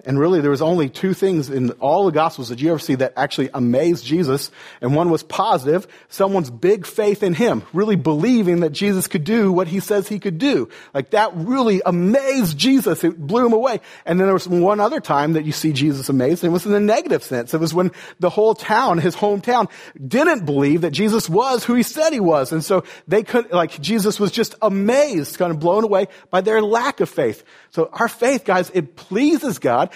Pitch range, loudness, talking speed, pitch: 160-215 Hz, -18 LUFS, 220 wpm, 185 Hz